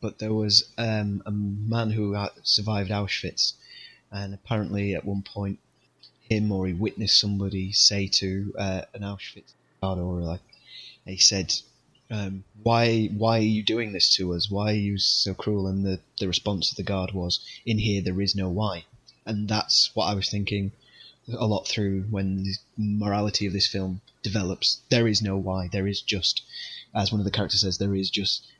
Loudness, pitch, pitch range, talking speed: -25 LUFS, 100 Hz, 95-110 Hz, 185 wpm